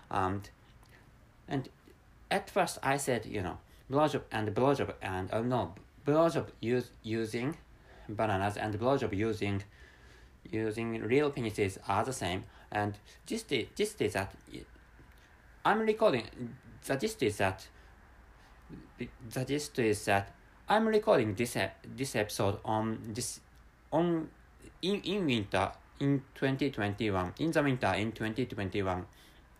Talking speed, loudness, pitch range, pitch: 125 wpm, -33 LUFS, 100-130 Hz, 110 Hz